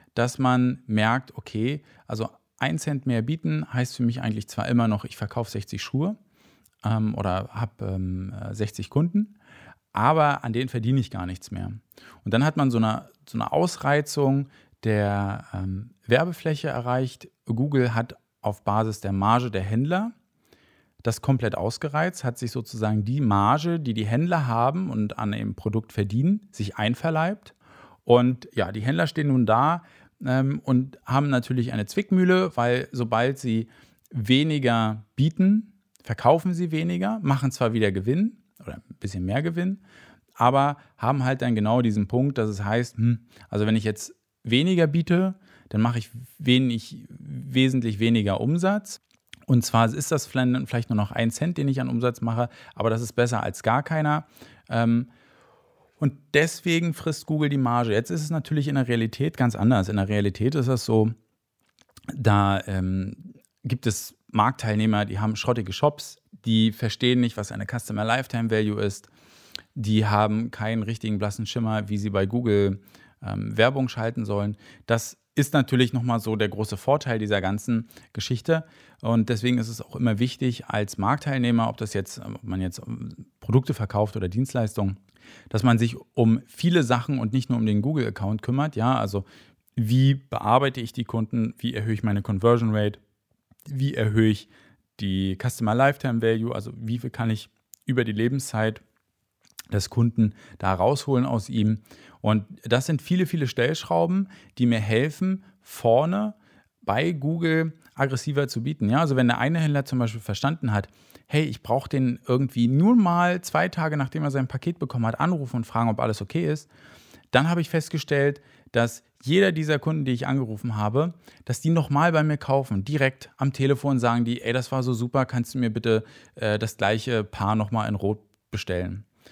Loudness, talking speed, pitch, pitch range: -25 LUFS, 170 wpm, 120 Hz, 110-140 Hz